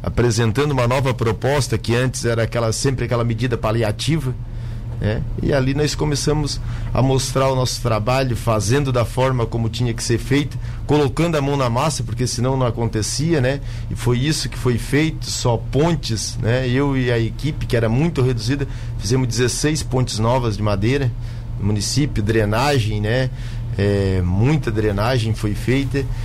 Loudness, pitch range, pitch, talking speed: -19 LUFS, 115-130 Hz, 120 Hz, 165 wpm